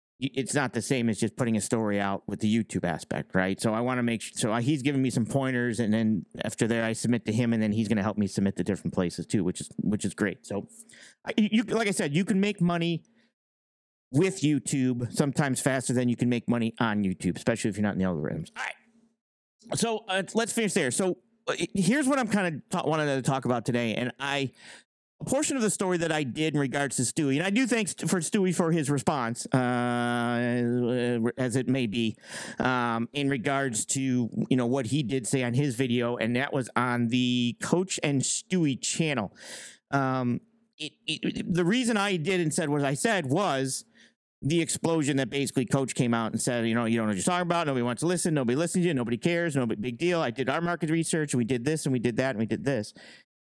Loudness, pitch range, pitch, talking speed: -27 LUFS, 120-170 Hz, 135 Hz, 235 wpm